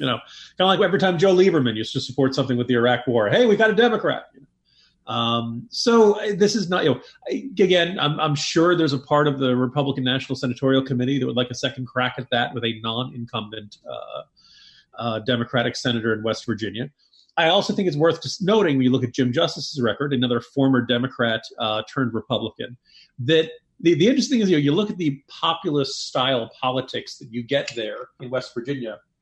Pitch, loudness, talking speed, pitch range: 130 Hz, -21 LUFS, 210 wpm, 120-165 Hz